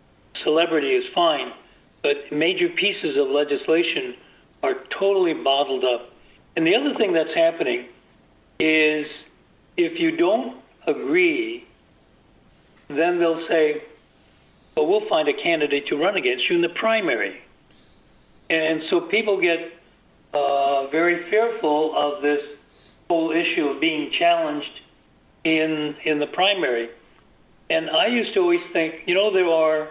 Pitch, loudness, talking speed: 170 Hz, -21 LUFS, 130 wpm